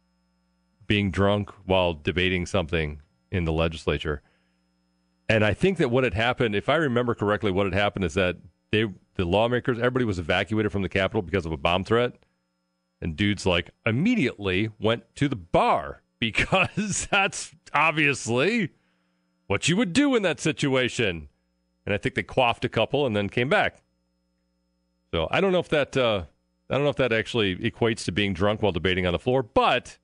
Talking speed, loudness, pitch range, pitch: 180 wpm, -24 LUFS, 75-115 Hz, 100 Hz